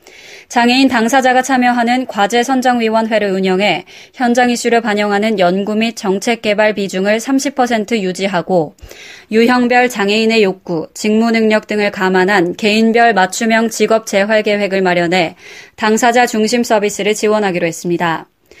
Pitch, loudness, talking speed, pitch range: 220 Hz, -13 LUFS, 315 characters per minute, 200-240 Hz